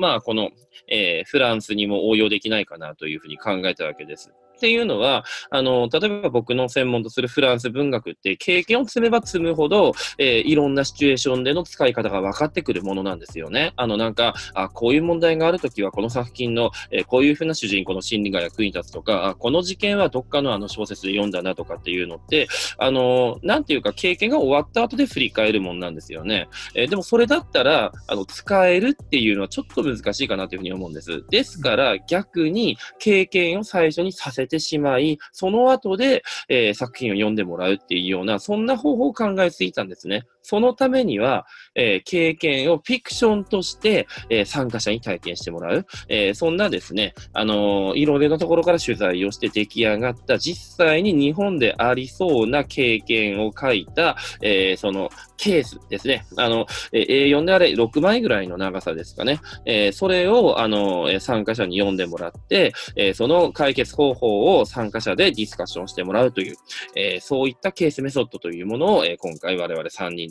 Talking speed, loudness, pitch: 420 characters per minute, -20 LUFS, 130 Hz